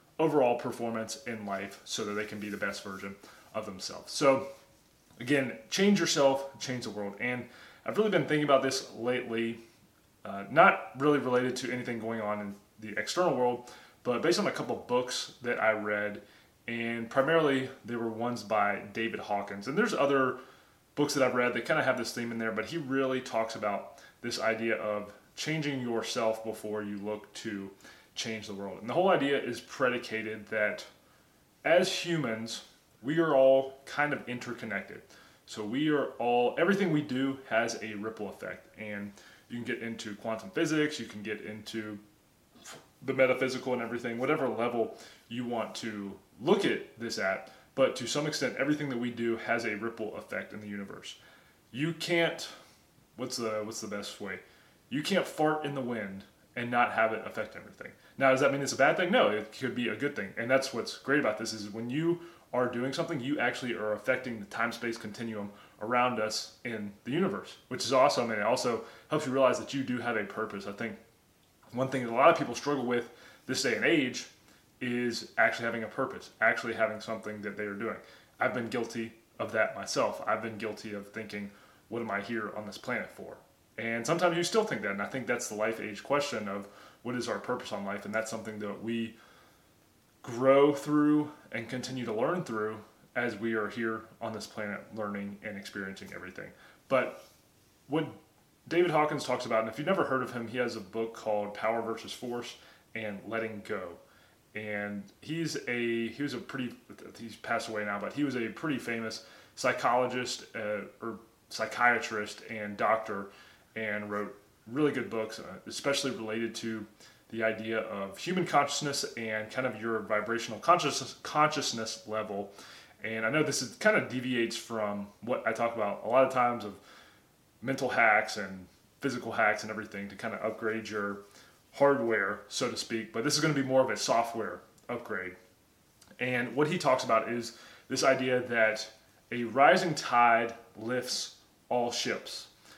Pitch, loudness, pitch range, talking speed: 115 Hz, -31 LUFS, 105-130 Hz, 190 wpm